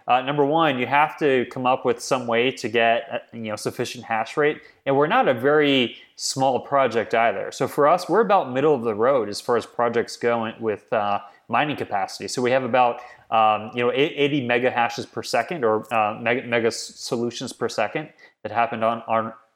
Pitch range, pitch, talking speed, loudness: 115-130 Hz, 120 Hz, 205 wpm, -22 LUFS